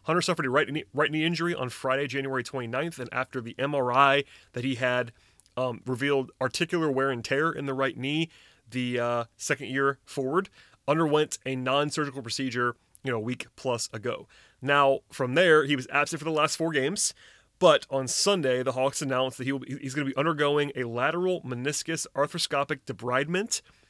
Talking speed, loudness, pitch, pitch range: 190 wpm, -27 LUFS, 135 Hz, 130-150 Hz